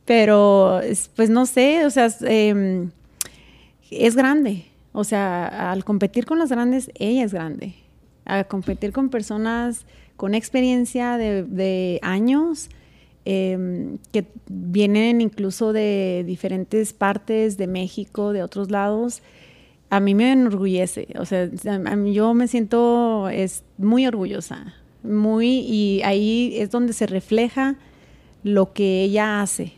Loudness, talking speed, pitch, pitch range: -20 LUFS, 130 wpm, 210 Hz, 195-235 Hz